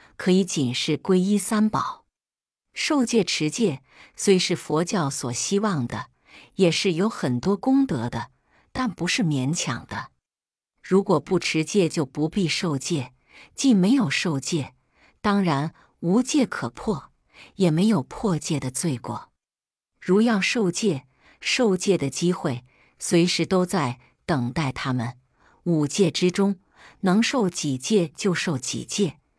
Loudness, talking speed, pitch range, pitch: -23 LUFS, 190 characters per minute, 145-200 Hz, 175 Hz